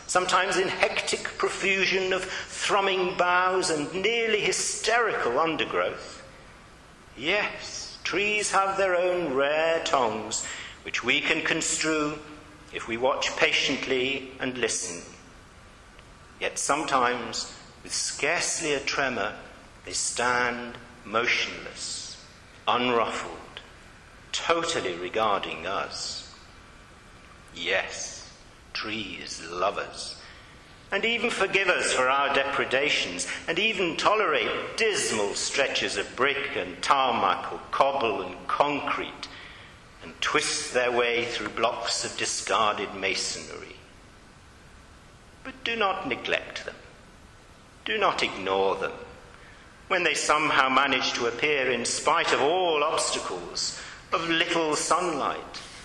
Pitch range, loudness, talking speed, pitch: 140-195 Hz, -26 LUFS, 105 wpm, 170 Hz